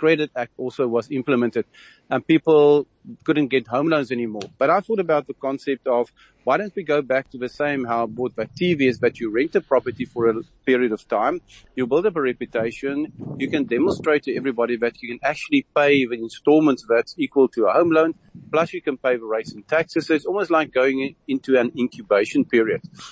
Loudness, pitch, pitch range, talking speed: -21 LUFS, 135 Hz, 125-160 Hz, 215 wpm